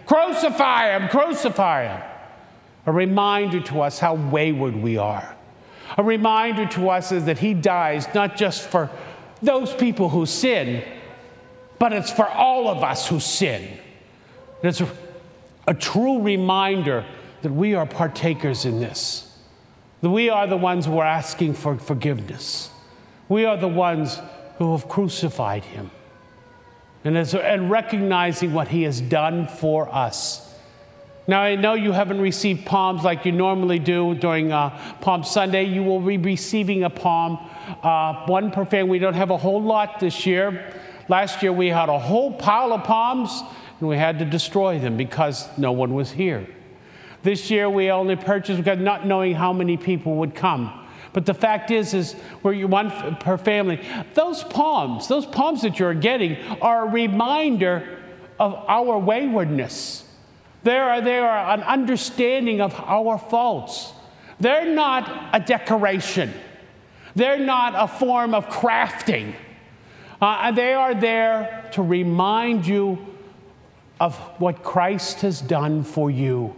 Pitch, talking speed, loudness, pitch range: 185 Hz, 155 wpm, -21 LUFS, 160-210 Hz